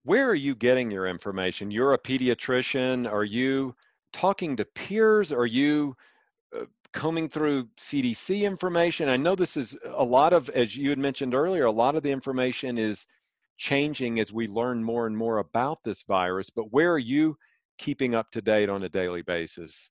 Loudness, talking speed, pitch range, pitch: -26 LUFS, 185 wpm, 115-155 Hz, 130 Hz